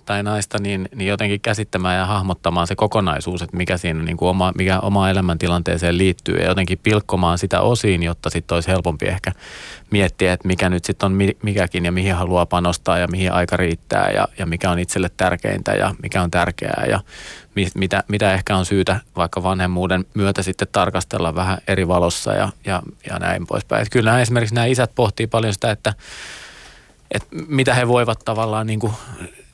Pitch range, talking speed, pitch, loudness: 90-105 Hz, 185 wpm, 95 Hz, -19 LUFS